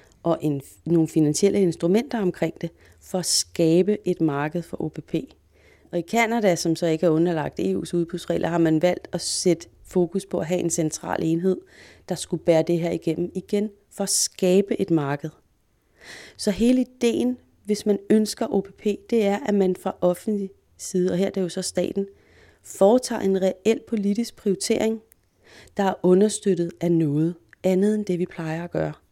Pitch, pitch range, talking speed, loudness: 180 Hz, 165-200 Hz, 175 wpm, -23 LUFS